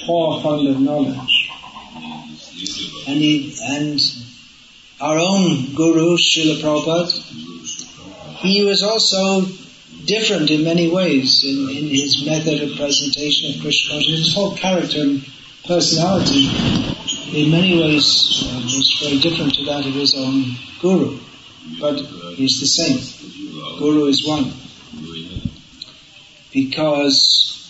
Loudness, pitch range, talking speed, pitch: -16 LUFS, 135-165 Hz, 115 wpm, 145 Hz